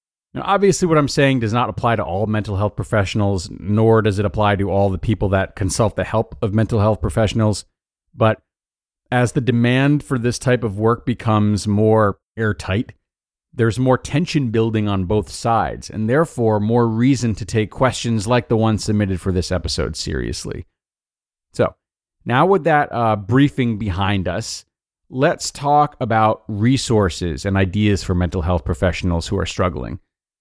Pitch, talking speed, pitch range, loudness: 110 Hz, 165 wpm, 100-120 Hz, -18 LUFS